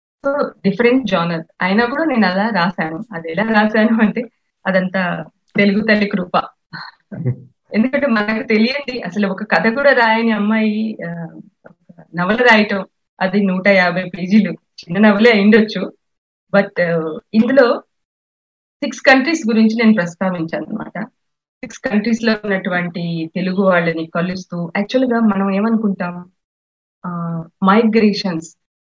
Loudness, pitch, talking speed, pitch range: -16 LUFS, 200 Hz, 110 wpm, 180-225 Hz